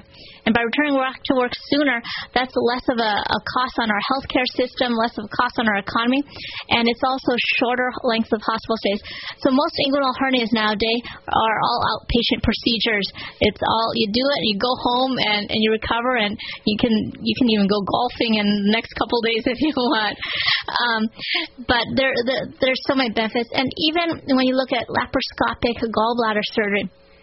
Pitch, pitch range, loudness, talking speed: 245 Hz, 225-260 Hz, -20 LUFS, 190 wpm